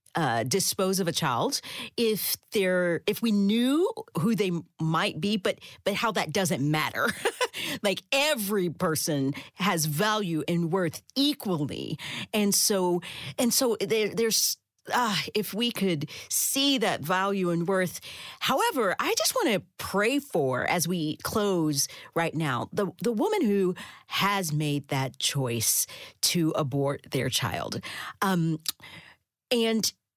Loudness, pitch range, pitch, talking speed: -27 LUFS, 155-215 Hz, 185 Hz, 135 wpm